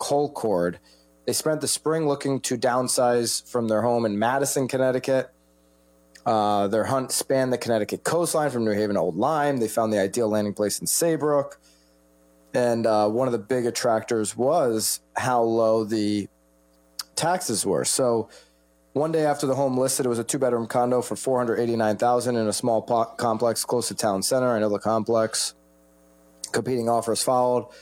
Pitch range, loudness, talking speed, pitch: 100-130 Hz, -24 LUFS, 175 wpm, 115 Hz